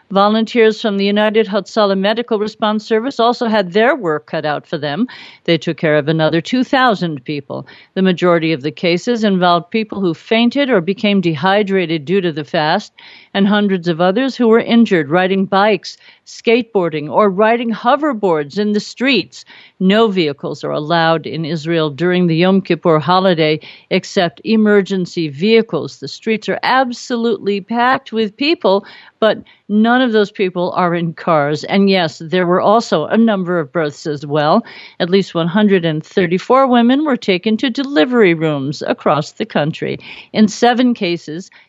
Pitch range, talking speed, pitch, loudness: 170-225 Hz, 160 wpm, 195 Hz, -15 LUFS